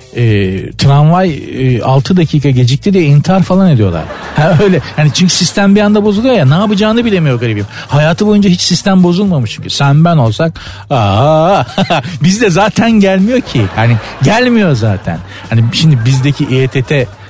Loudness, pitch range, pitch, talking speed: -9 LUFS, 125-190 Hz, 150 Hz, 155 wpm